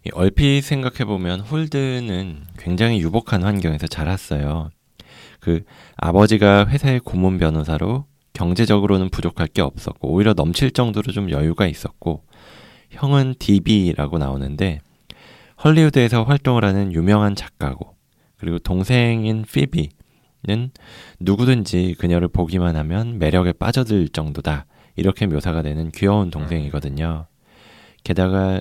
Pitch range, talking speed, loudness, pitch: 85-115 Hz, 300 characters per minute, -19 LUFS, 95 Hz